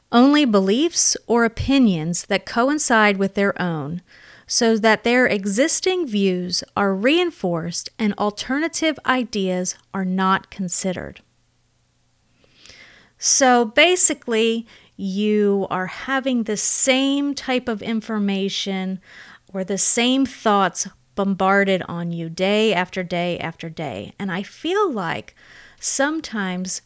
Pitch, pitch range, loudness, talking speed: 205 Hz, 190-255 Hz, -19 LUFS, 110 wpm